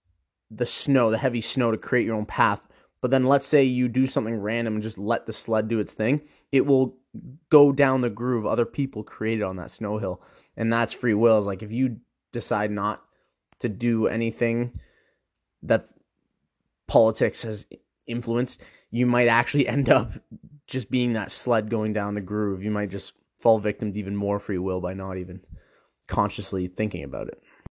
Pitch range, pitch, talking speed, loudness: 105-125 Hz, 115 Hz, 185 wpm, -25 LUFS